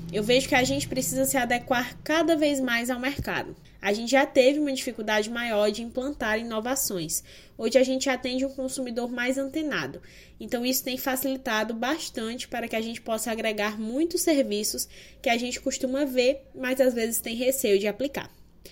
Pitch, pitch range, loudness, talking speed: 255 Hz, 225-265 Hz, -26 LUFS, 180 wpm